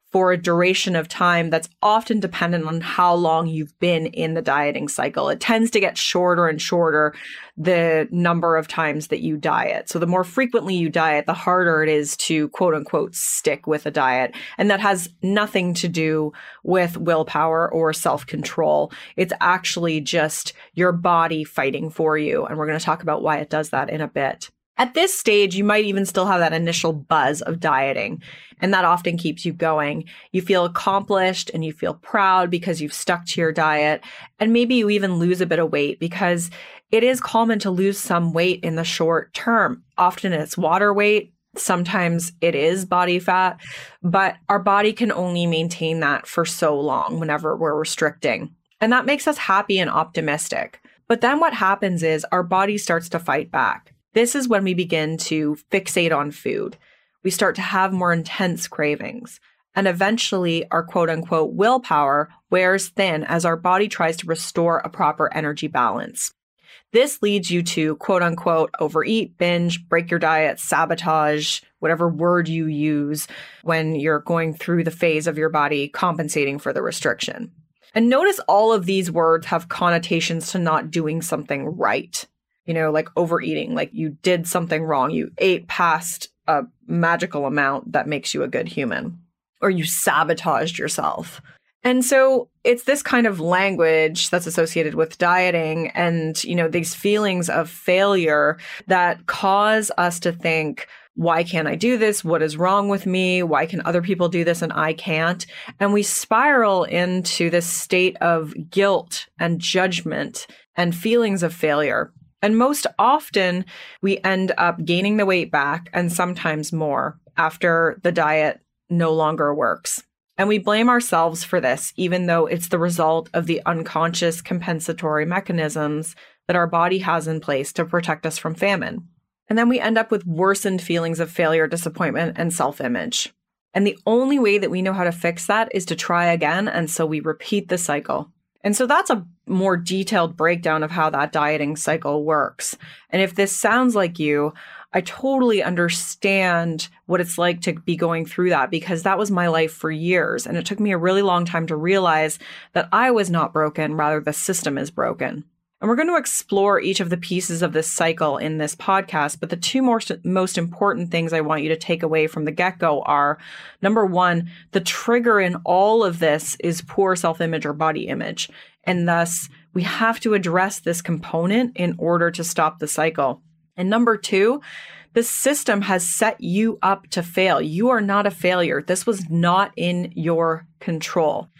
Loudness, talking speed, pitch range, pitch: -20 LUFS, 180 wpm, 160-195 Hz, 170 Hz